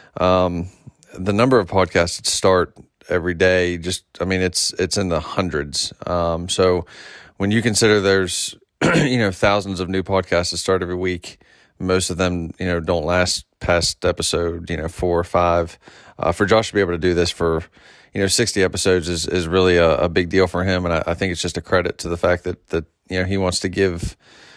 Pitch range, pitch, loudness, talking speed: 85-95 Hz, 90 Hz, -19 LUFS, 215 wpm